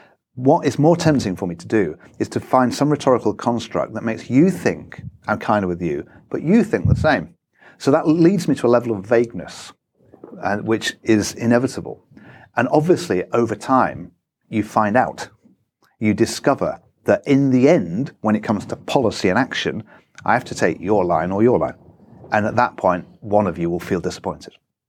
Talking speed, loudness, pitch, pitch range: 195 wpm, -19 LUFS, 115 Hz, 105-135 Hz